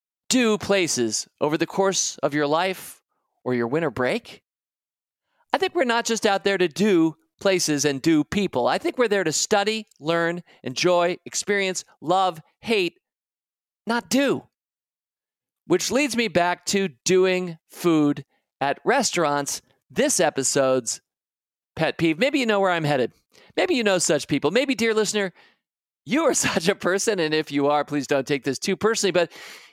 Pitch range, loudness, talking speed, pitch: 150-205 Hz, -22 LUFS, 165 wpm, 180 Hz